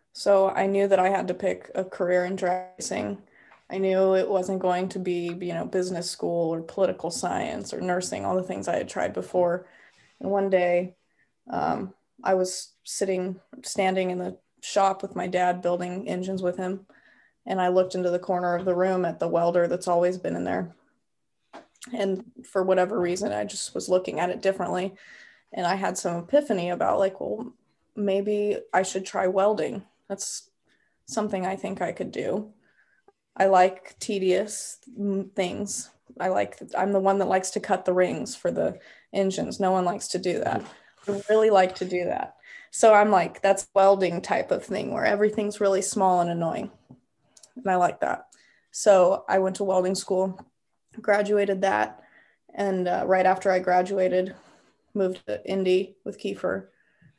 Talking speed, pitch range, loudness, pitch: 175 wpm, 180-195 Hz, -25 LUFS, 190 Hz